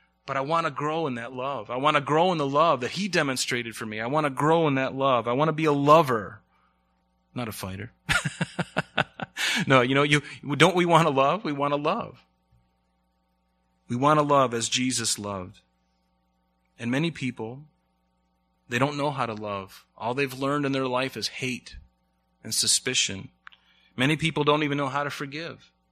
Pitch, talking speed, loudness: 125 Hz, 190 wpm, -25 LUFS